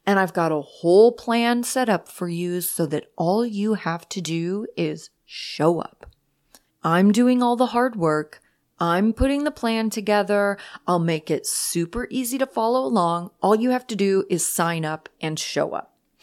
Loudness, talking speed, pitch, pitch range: -22 LUFS, 185 wpm, 200 Hz, 170-235 Hz